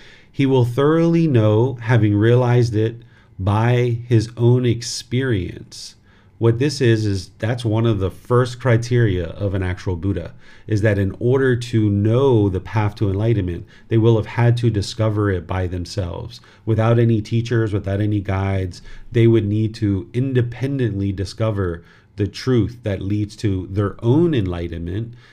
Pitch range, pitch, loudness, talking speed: 100-120 Hz, 110 Hz, -19 LUFS, 150 wpm